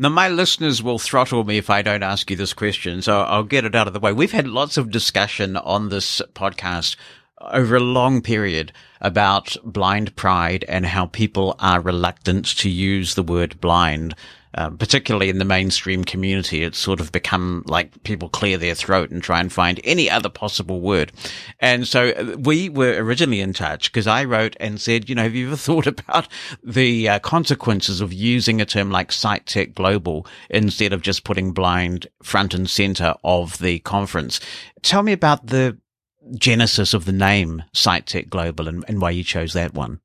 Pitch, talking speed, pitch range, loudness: 100 Hz, 190 wpm, 90-115 Hz, -19 LUFS